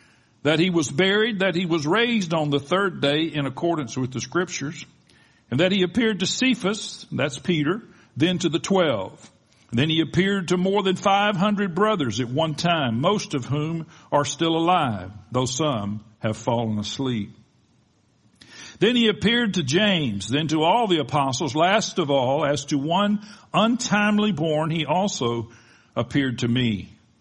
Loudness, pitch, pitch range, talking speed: -22 LUFS, 160 Hz, 130-195 Hz, 165 wpm